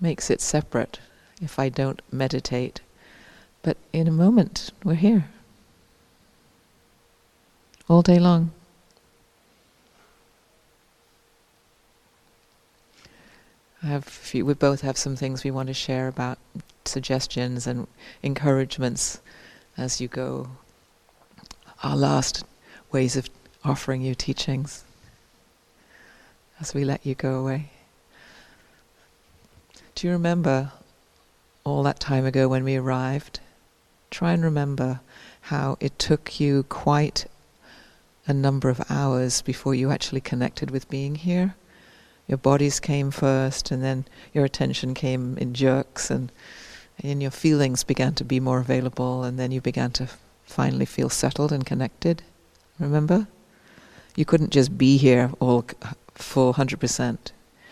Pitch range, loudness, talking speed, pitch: 130-150 Hz, -24 LUFS, 120 wpm, 135 Hz